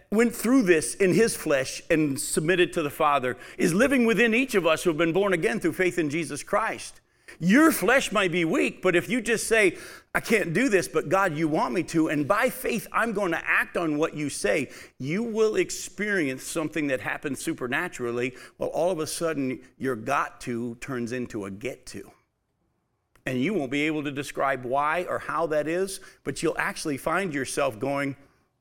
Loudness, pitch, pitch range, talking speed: -25 LUFS, 160 Hz, 140-190 Hz, 200 wpm